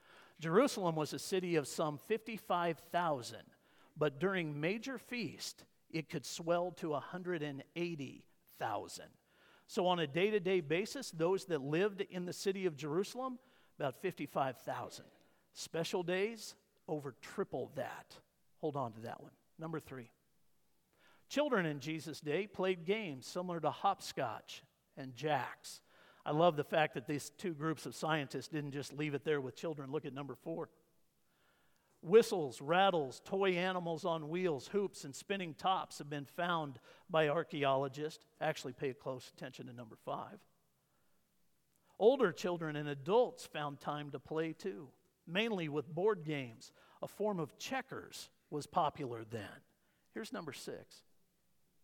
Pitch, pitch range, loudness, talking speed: 160 Hz, 145-185 Hz, -38 LUFS, 140 wpm